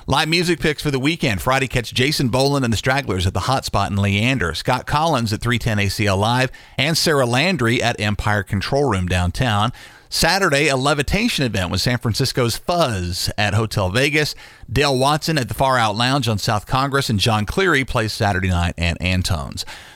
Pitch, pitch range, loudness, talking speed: 125 Hz, 105-140 Hz, -18 LUFS, 185 wpm